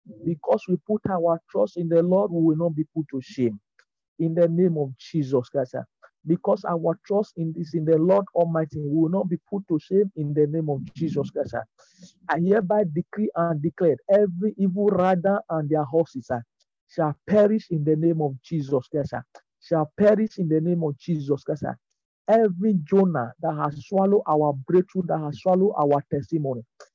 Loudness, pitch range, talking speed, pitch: -24 LUFS, 155-190 Hz, 185 wpm, 170 Hz